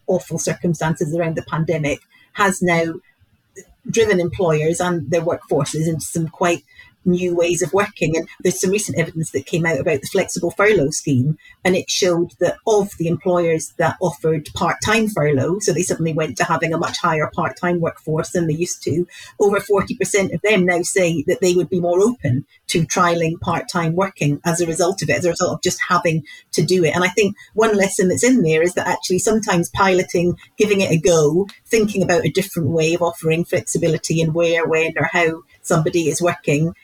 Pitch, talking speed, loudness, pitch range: 175 Hz, 200 wpm, -18 LUFS, 165-185 Hz